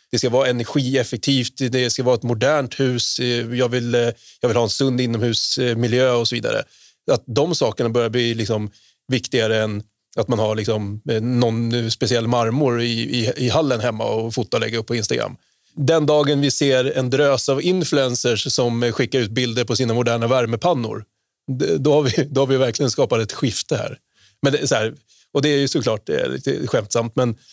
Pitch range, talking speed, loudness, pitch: 115-135 Hz, 190 wpm, -20 LUFS, 125 Hz